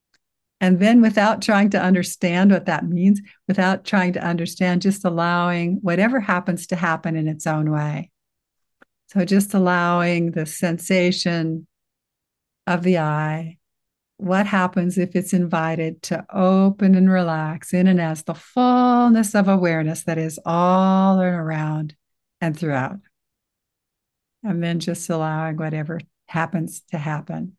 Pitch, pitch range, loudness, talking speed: 180 Hz, 165-190 Hz, -20 LUFS, 135 wpm